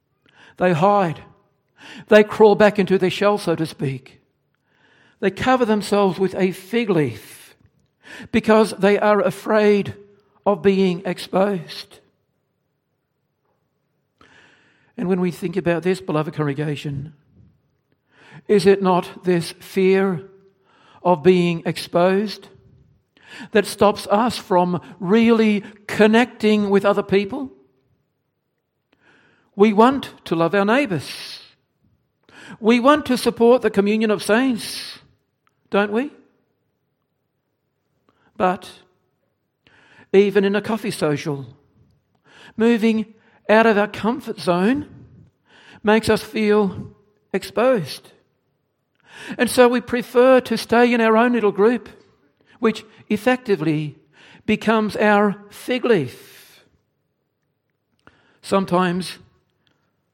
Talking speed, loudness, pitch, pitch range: 100 wpm, -19 LUFS, 200 Hz, 180-220 Hz